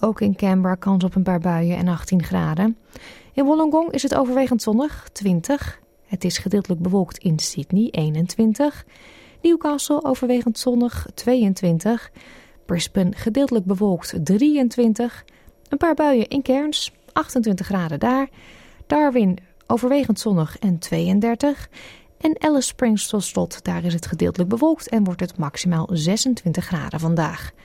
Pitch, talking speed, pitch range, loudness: 210 Hz, 135 wpm, 180-260 Hz, -21 LUFS